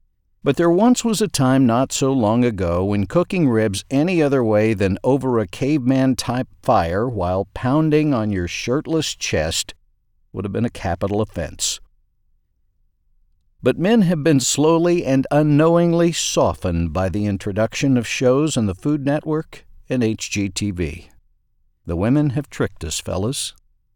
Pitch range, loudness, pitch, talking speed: 100-150 Hz, -19 LUFS, 120 Hz, 145 wpm